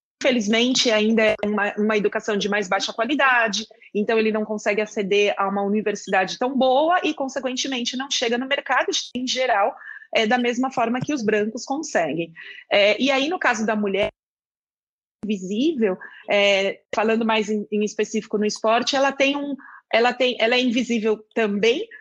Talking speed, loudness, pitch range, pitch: 165 wpm, -21 LUFS, 210-260 Hz, 225 Hz